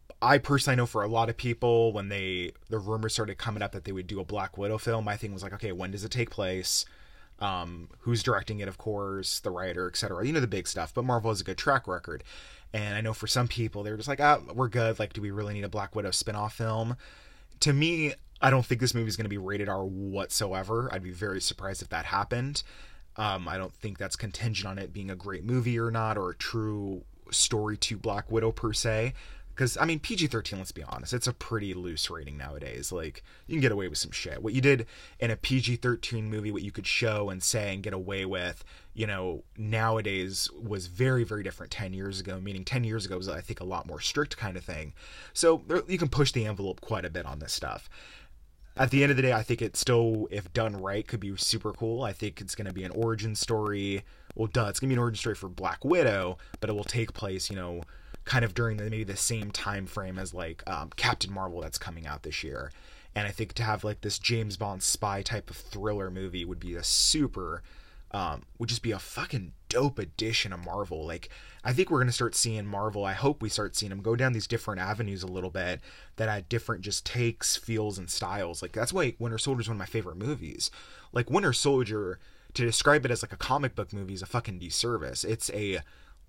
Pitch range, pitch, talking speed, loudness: 95-115 Hz, 105 Hz, 245 wpm, -30 LUFS